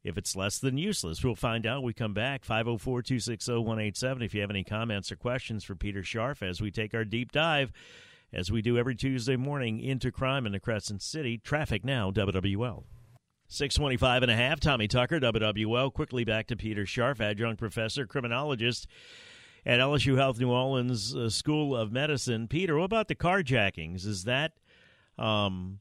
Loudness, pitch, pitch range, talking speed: -30 LUFS, 120 Hz, 110-135 Hz, 180 wpm